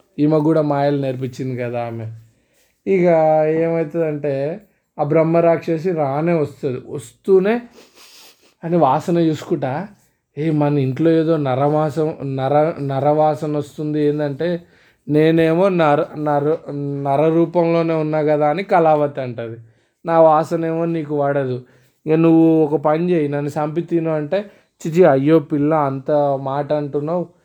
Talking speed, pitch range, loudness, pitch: 120 wpm, 145-165 Hz, -18 LUFS, 155 Hz